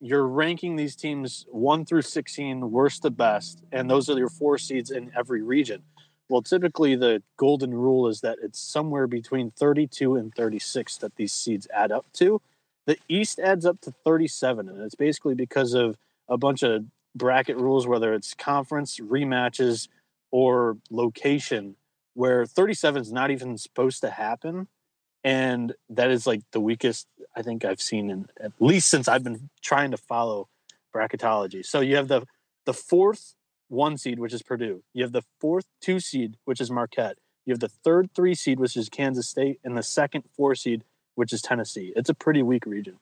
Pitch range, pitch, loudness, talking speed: 120-150 Hz, 130 Hz, -25 LUFS, 185 wpm